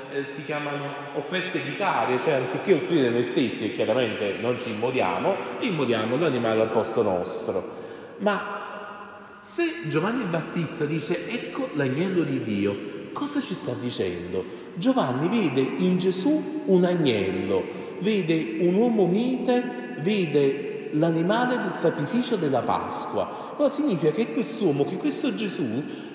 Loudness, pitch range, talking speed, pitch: -25 LUFS, 145-225 Hz, 125 wpm, 175 Hz